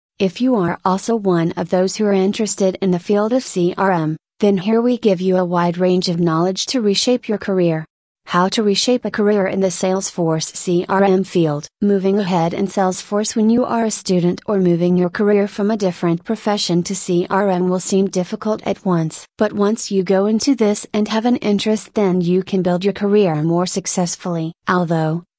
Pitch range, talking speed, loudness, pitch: 180-210 Hz, 195 wpm, -17 LUFS, 195 Hz